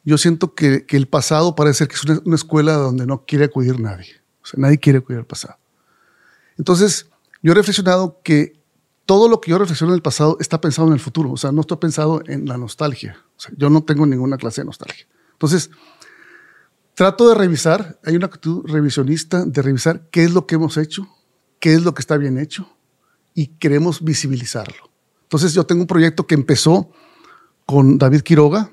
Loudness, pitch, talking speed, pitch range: -16 LUFS, 155 Hz, 200 wpm, 145-175 Hz